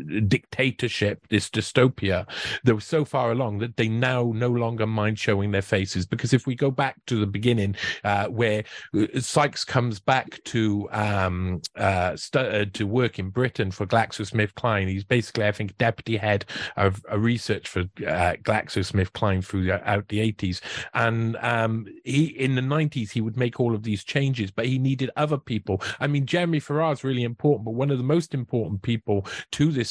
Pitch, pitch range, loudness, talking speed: 115 Hz, 105-130 Hz, -25 LUFS, 185 wpm